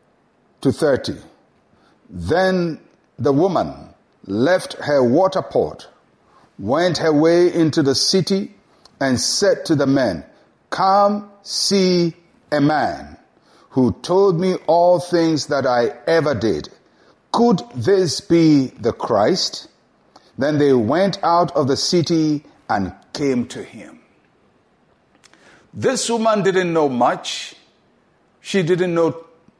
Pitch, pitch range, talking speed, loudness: 165 Hz, 145-185 Hz, 115 wpm, -18 LUFS